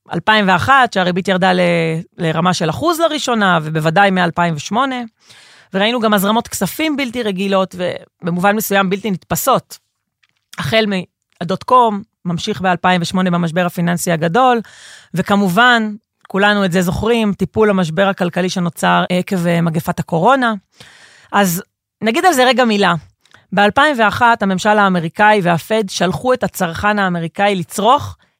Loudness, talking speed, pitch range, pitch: -15 LUFS, 115 wpm, 175-215 Hz, 195 Hz